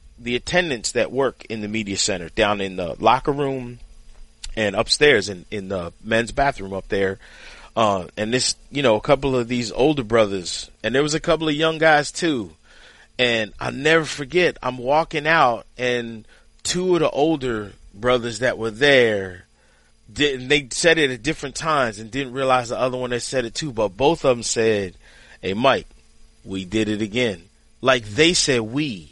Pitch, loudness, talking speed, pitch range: 120 Hz, -20 LUFS, 185 wpm, 110-145 Hz